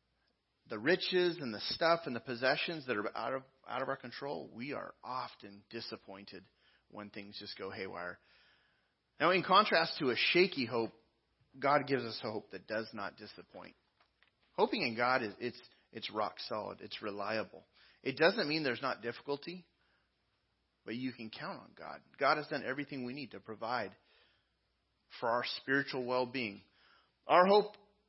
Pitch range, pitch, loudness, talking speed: 110-140 Hz, 125 Hz, -35 LUFS, 165 wpm